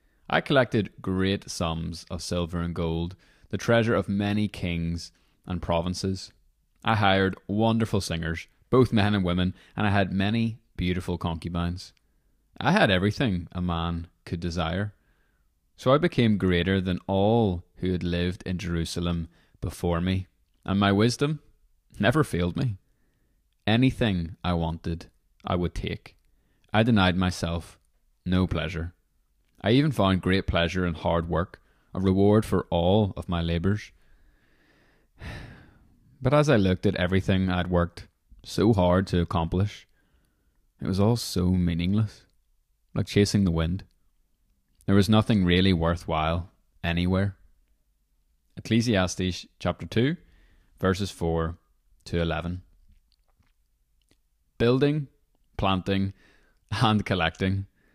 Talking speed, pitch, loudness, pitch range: 125 wpm, 90 Hz, -26 LUFS, 85-100 Hz